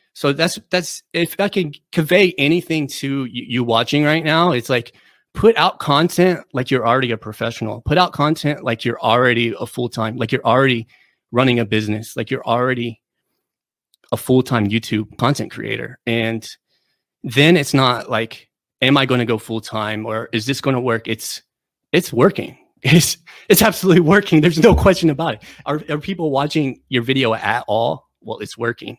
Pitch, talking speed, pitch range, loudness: 130 Hz, 180 wpm, 115-160 Hz, -17 LUFS